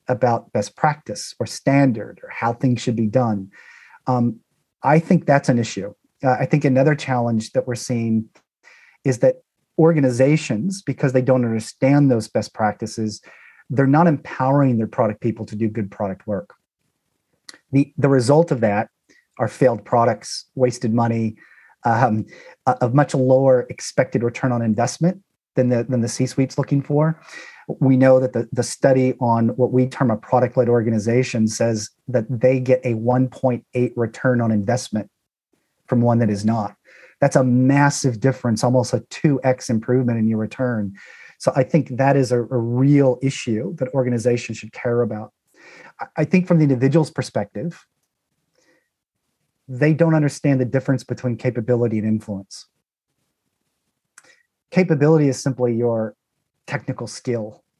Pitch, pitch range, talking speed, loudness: 125 Hz, 115-140 Hz, 155 wpm, -19 LUFS